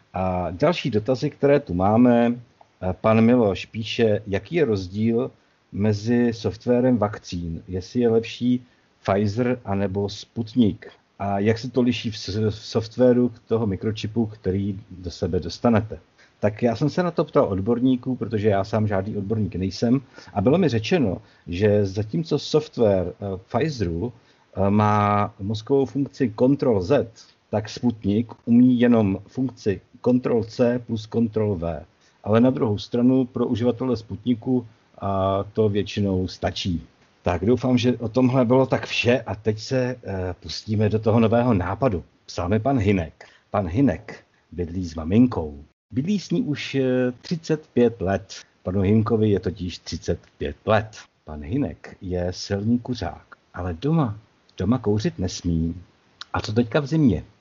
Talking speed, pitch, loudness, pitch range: 140 wpm, 110 Hz, -23 LUFS, 95-125 Hz